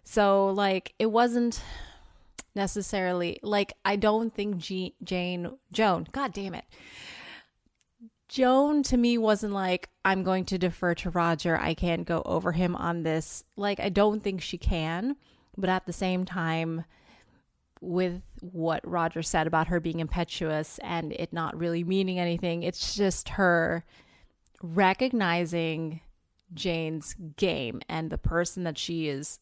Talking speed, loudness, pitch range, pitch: 145 wpm, -28 LUFS, 170-200 Hz, 180 Hz